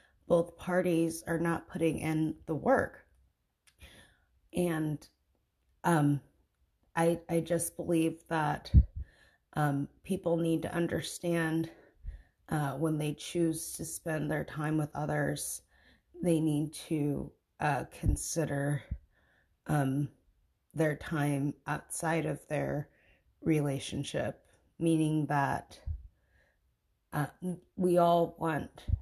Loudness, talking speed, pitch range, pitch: -32 LUFS, 100 wpm, 105-165 Hz, 155 Hz